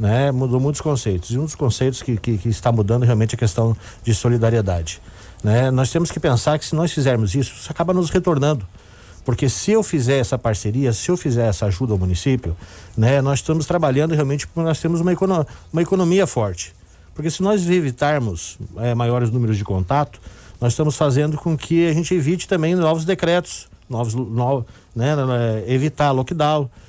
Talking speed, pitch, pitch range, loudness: 185 wpm, 130 Hz, 110-155 Hz, -19 LUFS